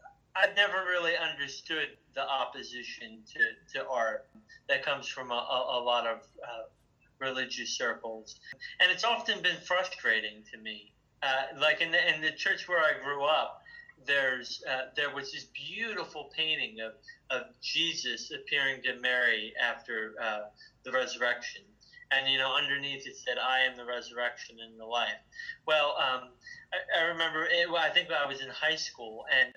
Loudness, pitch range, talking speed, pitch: -30 LUFS, 120-180 Hz, 170 wpm, 140 Hz